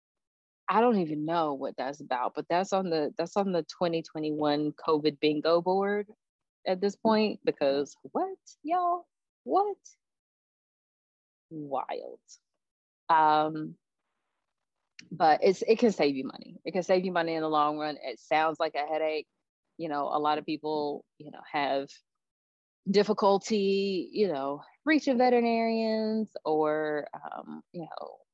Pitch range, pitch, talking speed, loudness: 150-205 Hz, 165 Hz, 145 wpm, -29 LUFS